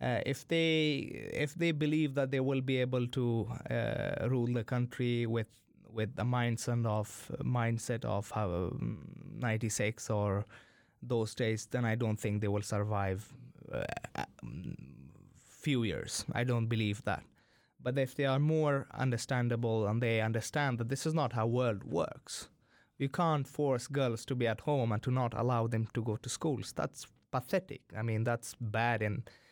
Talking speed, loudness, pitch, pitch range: 170 wpm, -34 LUFS, 120 Hz, 110-135 Hz